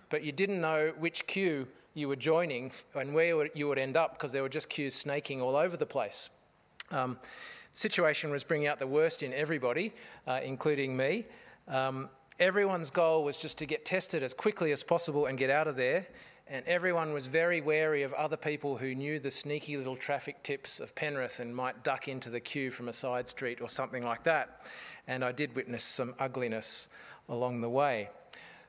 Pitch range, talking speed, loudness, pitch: 130-160 Hz, 200 wpm, -33 LUFS, 145 Hz